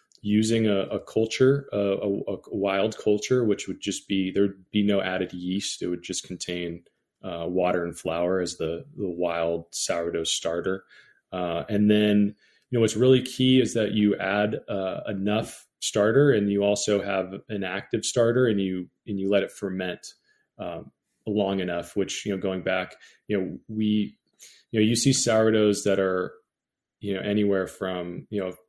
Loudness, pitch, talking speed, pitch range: -25 LUFS, 100 Hz, 180 wpm, 95-105 Hz